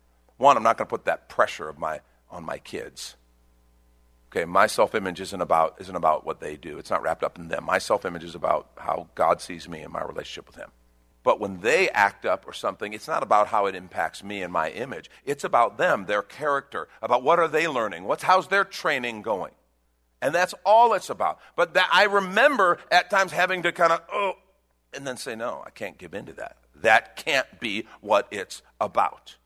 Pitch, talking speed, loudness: 100 Hz, 215 wpm, -24 LUFS